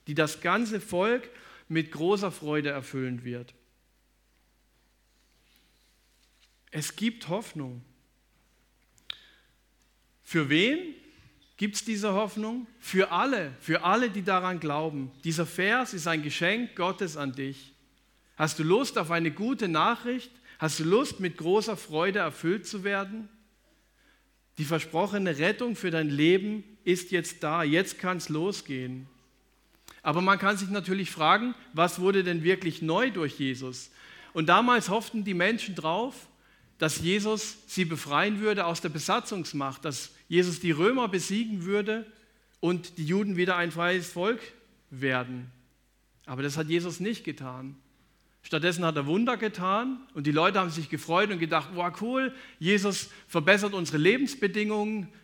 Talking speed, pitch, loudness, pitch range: 140 wpm, 180 Hz, -28 LUFS, 155-210 Hz